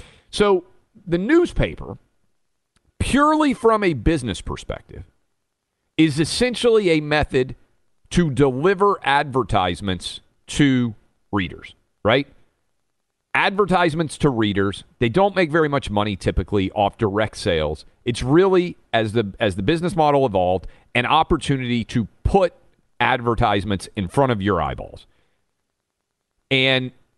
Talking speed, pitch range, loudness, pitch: 115 wpm, 105-170 Hz, -20 LUFS, 130 Hz